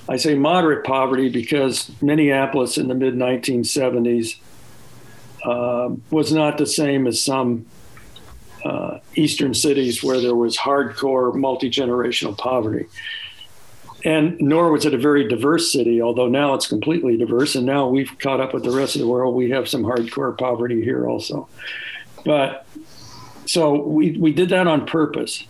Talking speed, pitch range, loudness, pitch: 155 wpm, 125-150 Hz, -19 LUFS, 135 Hz